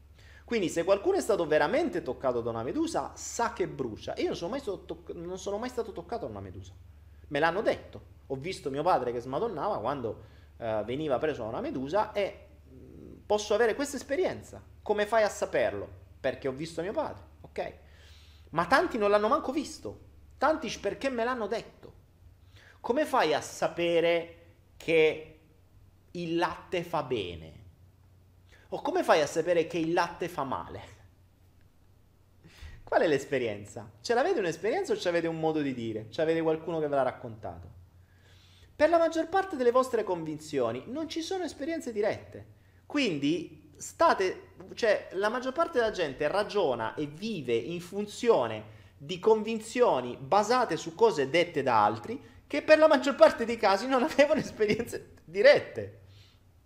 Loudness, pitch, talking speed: -29 LUFS, 165 Hz, 160 wpm